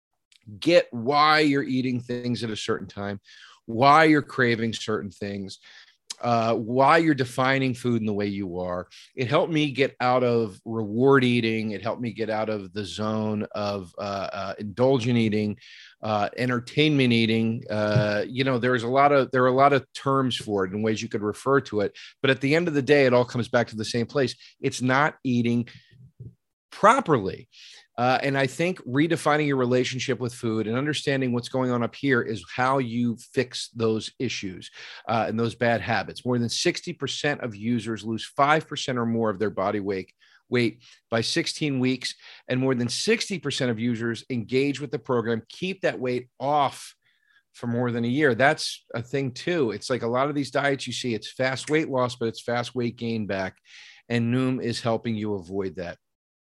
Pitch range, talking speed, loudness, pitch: 110-135 Hz, 195 wpm, -25 LUFS, 120 Hz